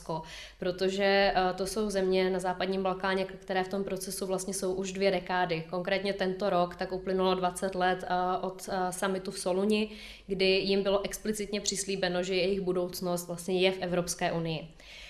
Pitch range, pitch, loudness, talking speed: 180-195 Hz, 190 Hz, -30 LUFS, 160 wpm